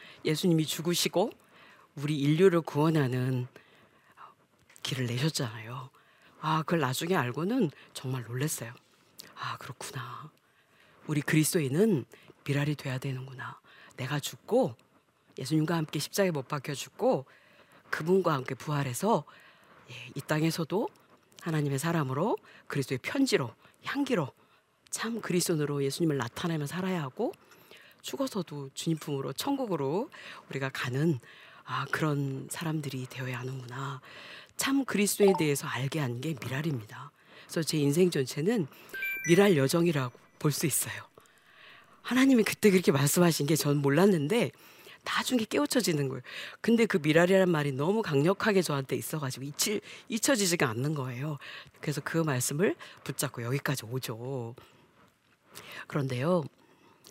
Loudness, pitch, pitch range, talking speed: -30 LUFS, 150 Hz, 135-180 Hz, 305 characters per minute